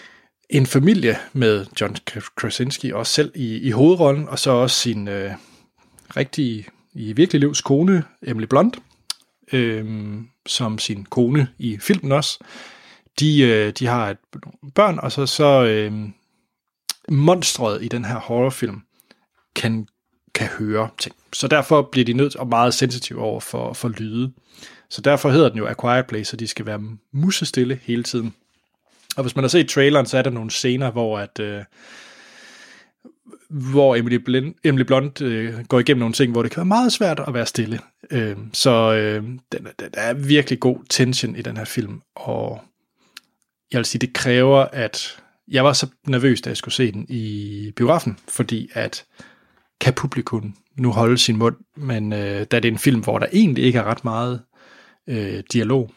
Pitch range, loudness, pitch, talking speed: 115-140 Hz, -19 LUFS, 125 Hz, 175 wpm